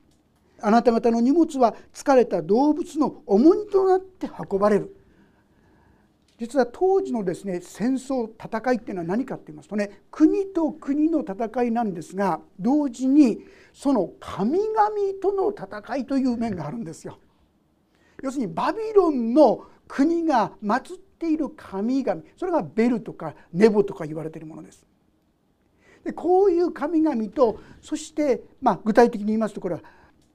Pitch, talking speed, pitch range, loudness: 255 Hz, 305 characters per minute, 210-310 Hz, -23 LUFS